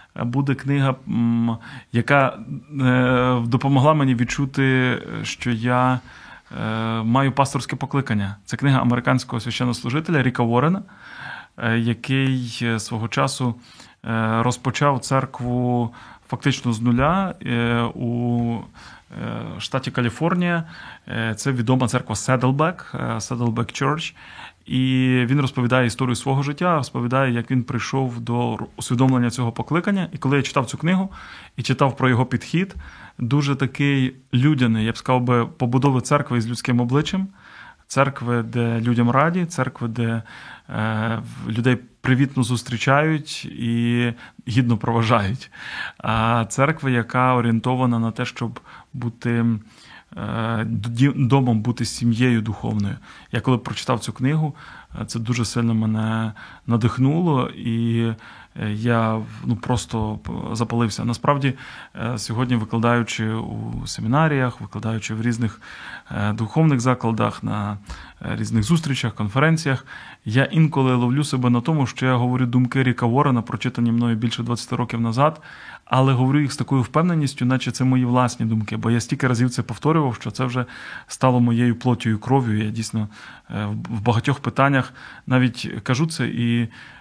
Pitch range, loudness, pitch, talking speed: 115-135 Hz, -21 LUFS, 125 Hz, 120 wpm